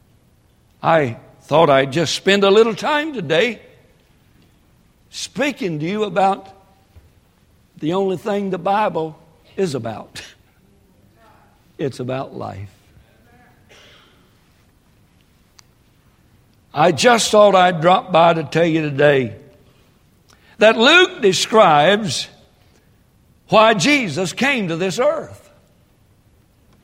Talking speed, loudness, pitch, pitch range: 95 wpm, -16 LUFS, 180 Hz, 135-205 Hz